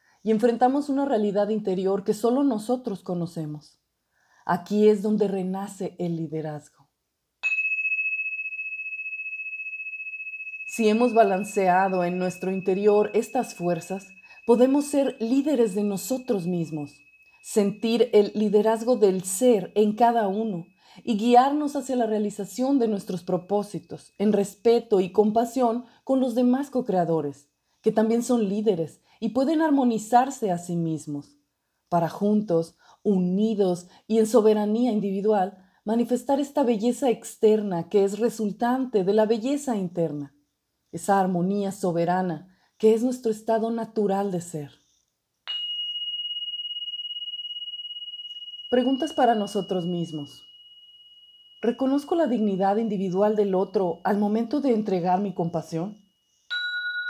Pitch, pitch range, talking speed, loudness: 215 Hz, 185-255 Hz, 110 wpm, -24 LUFS